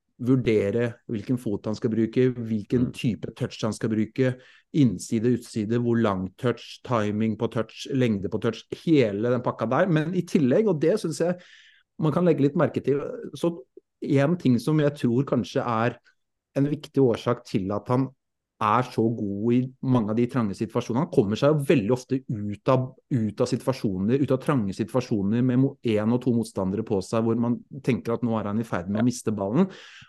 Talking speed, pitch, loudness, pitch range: 190 wpm, 120 Hz, -25 LUFS, 115-135 Hz